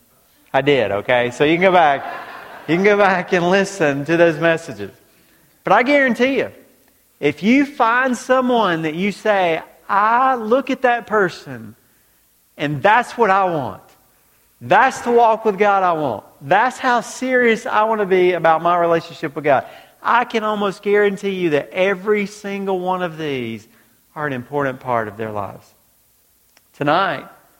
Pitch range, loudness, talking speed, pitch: 145-215 Hz, -17 LUFS, 165 wpm, 185 Hz